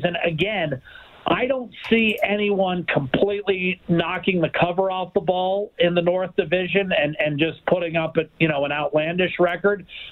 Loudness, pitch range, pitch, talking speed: -22 LUFS, 165-200 Hz, 180 Hz, 165 wpm